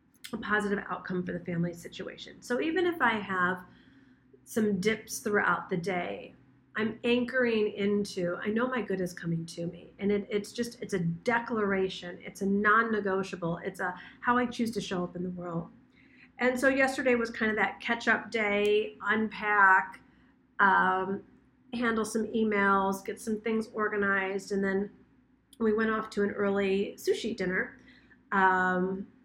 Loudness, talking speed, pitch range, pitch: -29 LUFS, 160 wpm, 190-225 Hz, 205 Hz